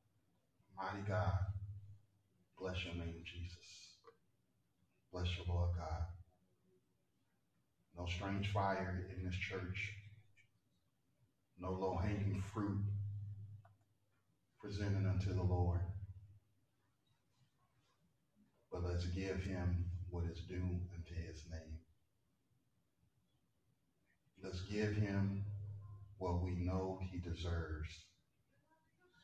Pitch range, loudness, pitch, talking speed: 90-100 Hz, -43 LUFS, 95 Hz, 85 wpm